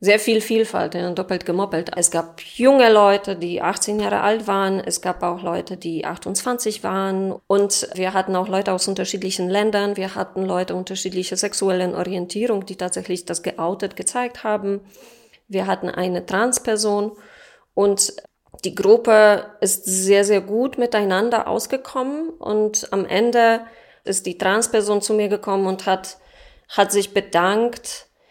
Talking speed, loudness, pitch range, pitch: 145 wpm, -20 LUFS, 185-220 Hz, 200 Hz